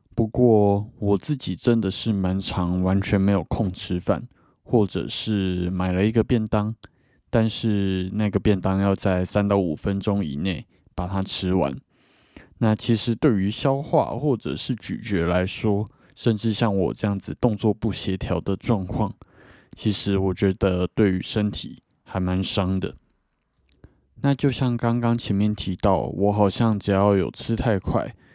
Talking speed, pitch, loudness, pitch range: 220 characters per minute, 100 Hz, -23 LUFS, 95-110 Hz